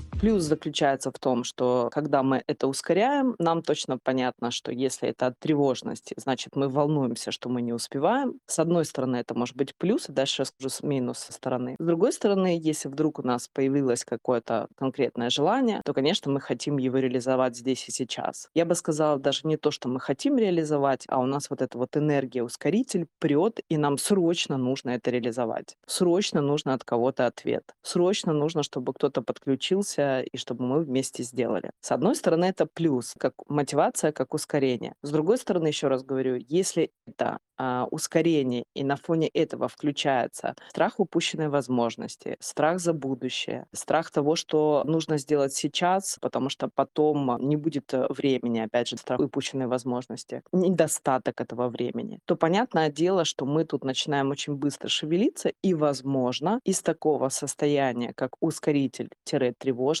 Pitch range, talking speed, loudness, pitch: 130-160 Hz, 170 wpm, -27 LUFS, 140 Hz